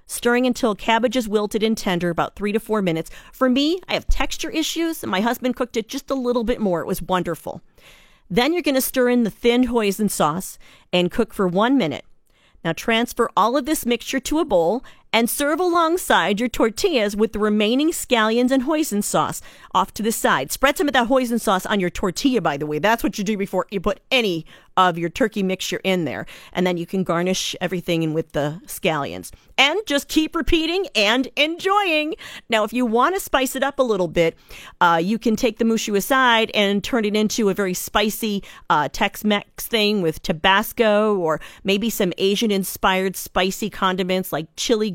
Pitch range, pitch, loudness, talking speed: 190-255 Hz, 220 Hz, -20 LUFS, 200 wpm